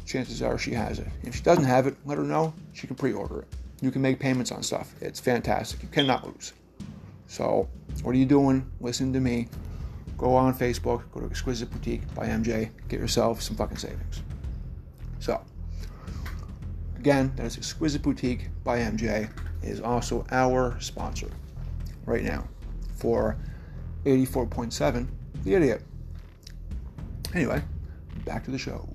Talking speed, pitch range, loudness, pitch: 155 wpm, 85-130 Hz, -28 LUFS, 115 Hz